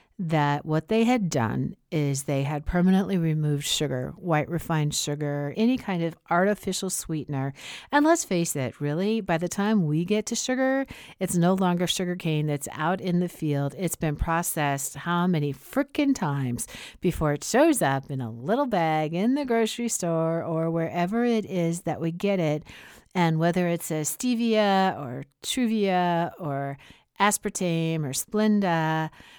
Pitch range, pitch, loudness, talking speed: 150-195 Hz, 170 Hz, -26 LUFS, 160 wpm